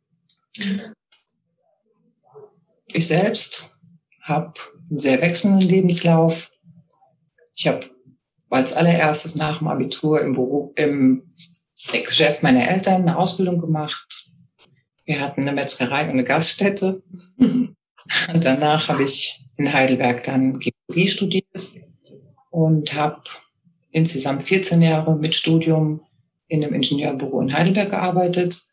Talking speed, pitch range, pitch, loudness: 110 wpm, 145-180 Hz, 160 Hz, -19 LUFS